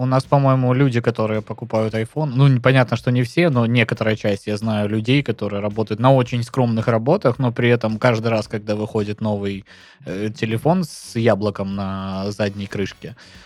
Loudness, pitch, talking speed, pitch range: -19 LUFS, 115 Hz, 175 wpm, 105-125 Hz